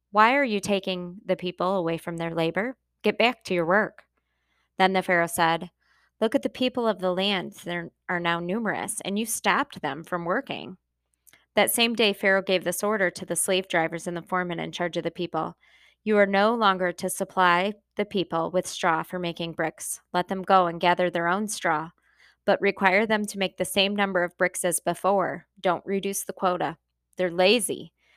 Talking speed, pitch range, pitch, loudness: 200 wpm, 175-200 Hz, 185 Hz, -25 LUFS